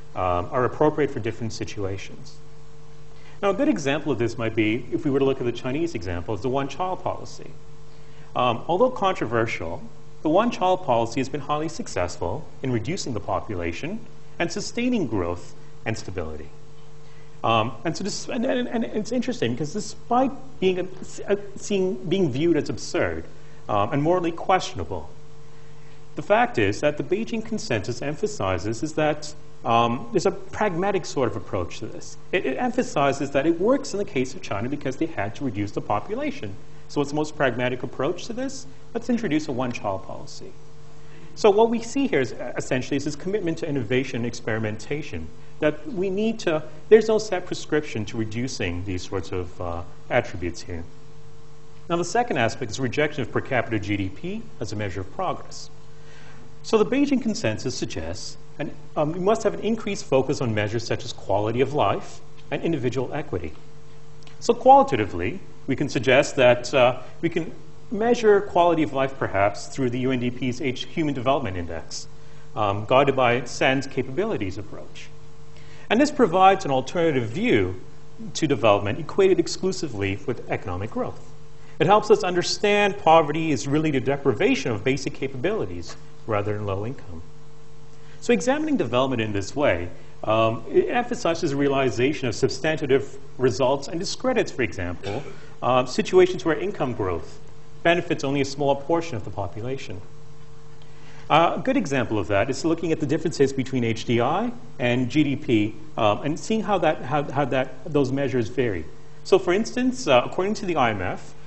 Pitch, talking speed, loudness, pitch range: 150 Hz, 165 wpm, -24 LUFS, 125-170 Hz